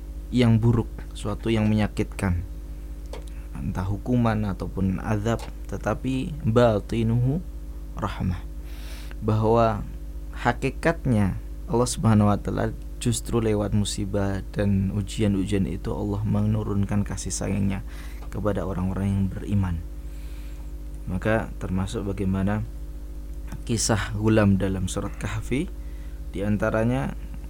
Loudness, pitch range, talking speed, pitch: -25 LUFS, 75-110 Hz, 90 wpm, 100 Hz